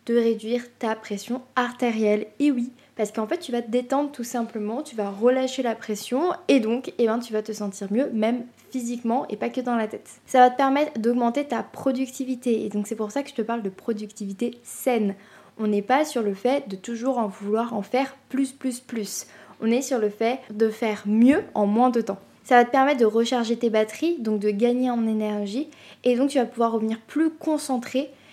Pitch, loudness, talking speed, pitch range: 235 Hz, -24 LUFS, 225 wpm, 220-260 Hz